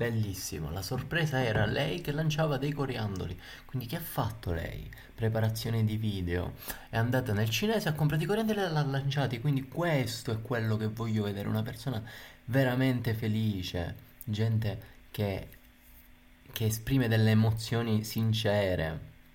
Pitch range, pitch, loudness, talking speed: 105-135 Hz, 115 Hz, -31 LUFS, 145 wpm